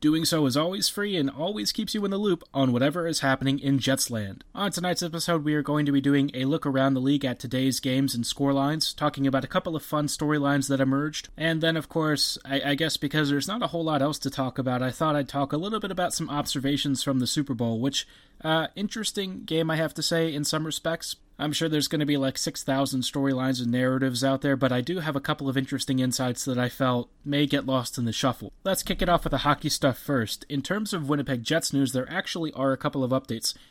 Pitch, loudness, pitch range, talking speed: 145 Hz, -26 LUFS, 135-160 Hz, 250 wpm